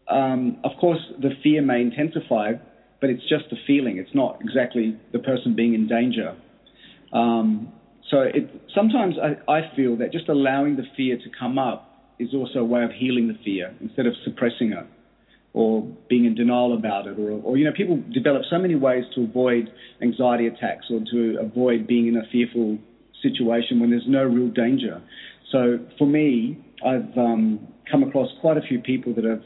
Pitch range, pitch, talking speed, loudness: 115-150 Hz, 125 Hz, 185 wpm, -22 LUFS